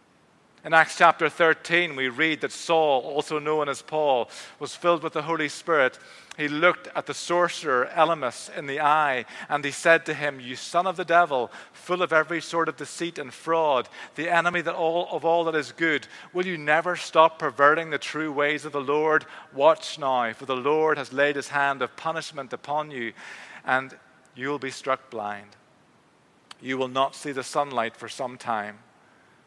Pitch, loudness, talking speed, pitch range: 155 Hz, -24 LUFS, 190 wpm, 140-165 Hz